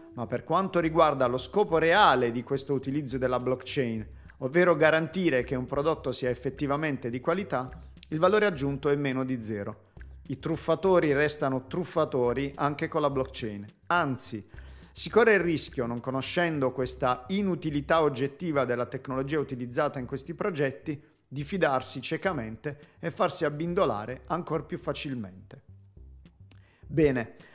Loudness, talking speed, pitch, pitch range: -28 LUFS, 135 wpm, 140 Hz, 125-160 Hz